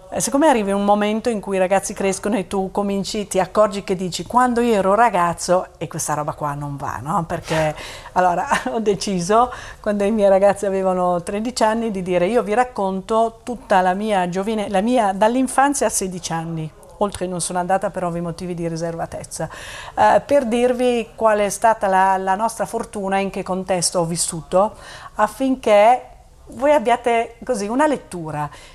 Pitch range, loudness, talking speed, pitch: 180-225 Hz, -19 LUFS, 175 wpm, 200 Hz